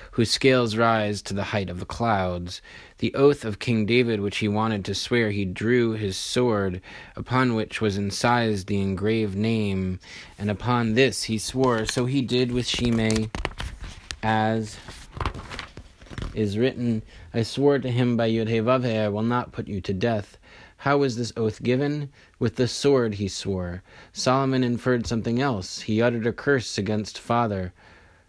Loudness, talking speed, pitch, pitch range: -24 LUFS, 160 wpm, 110 Hz, 100-120 Hz